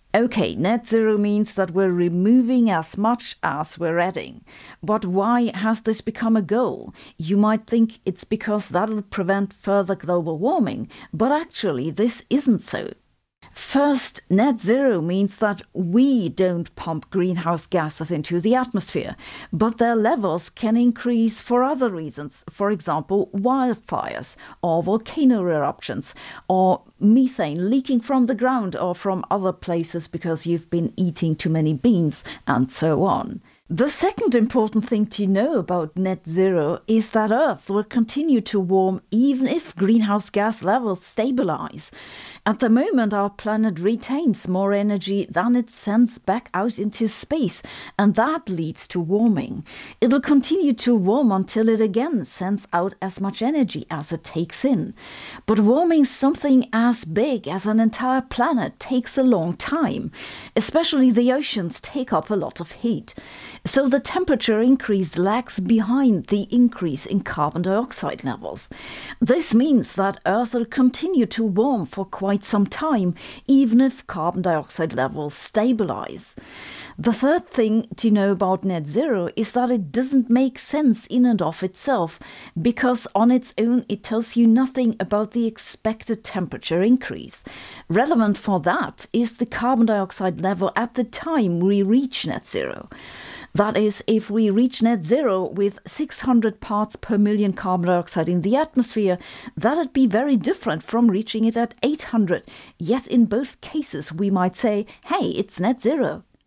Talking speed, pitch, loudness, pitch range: 155 wpm, 220 Hz, -21 LUFS, 190-245 Hz